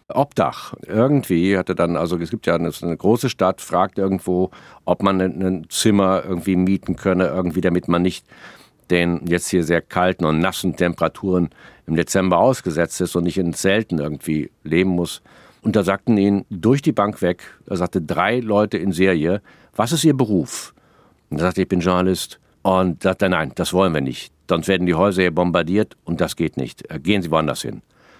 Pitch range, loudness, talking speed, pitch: 85-95 Hz, -20 LUFS, 190 wpm, 90 Hz